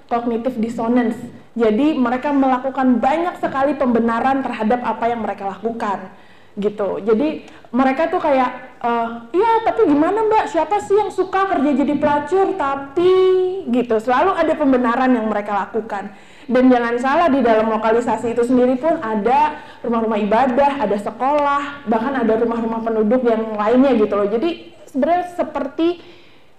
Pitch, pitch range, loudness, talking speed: 255 Hz, 230-295 Hz, -18 LUFS, 145 wpm